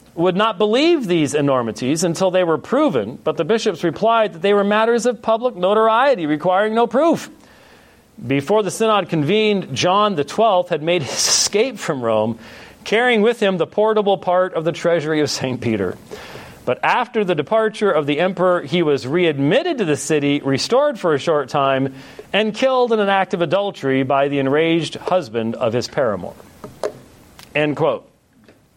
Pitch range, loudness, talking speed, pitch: 145-215 Hz, -18 LUFS, 170 wpm, 180 Hz